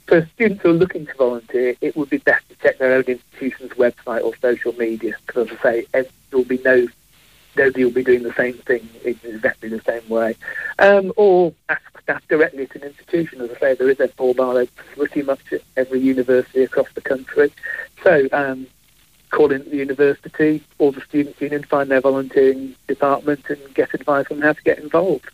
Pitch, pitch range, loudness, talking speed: 135 Hz, 125-150 Hz, -19 LUFS, 195 wpm